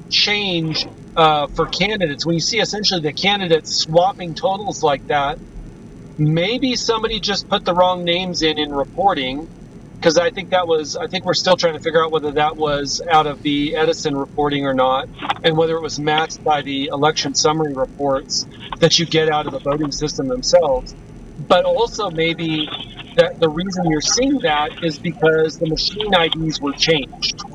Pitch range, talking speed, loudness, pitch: 150-180 Hz, 180 wpm, -18 LUFS, 160 Hz